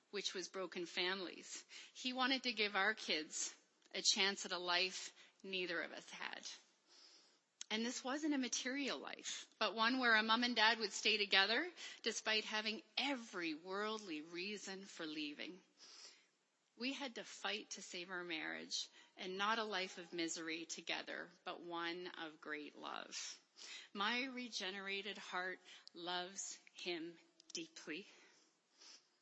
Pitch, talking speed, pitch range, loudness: 200 Hz, 140 wpm, 180-240 Hz, -41 LUFS